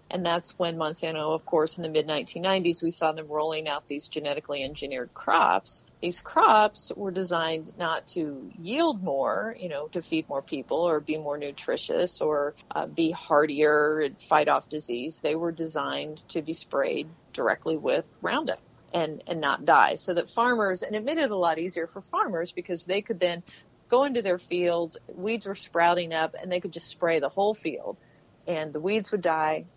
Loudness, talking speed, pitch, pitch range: -27 LUFS, 190 wpm, 170 Hz, 155-190 Hz